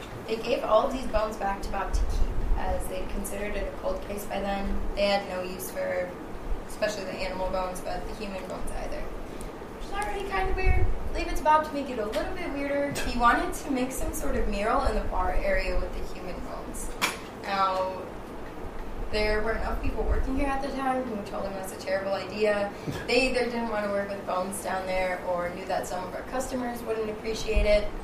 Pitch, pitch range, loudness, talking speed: 215 Hz, 195-260 Hz, -30 LUFS, 225 wpm